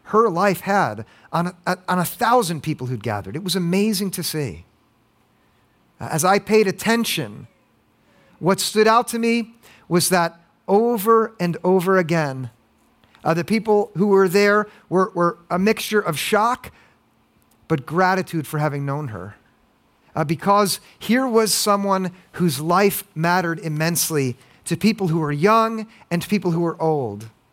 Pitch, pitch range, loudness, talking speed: 180 Hz, 160-205 Hz, -20 LUFS, 150 wpm